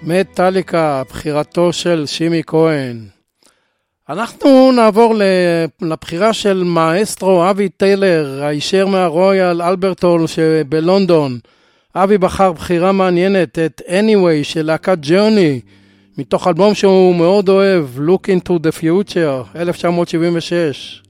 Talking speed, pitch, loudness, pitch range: 100 wpm, 175 Hz, -13 LUFS, 160-190 Hz